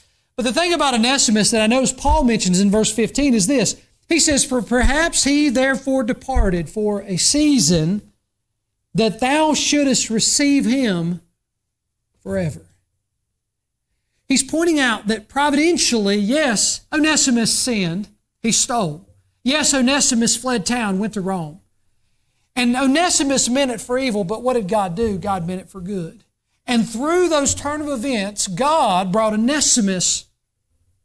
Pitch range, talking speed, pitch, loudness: 185-270 Hz, 140 wpm, 230 Hz, -17 LUFS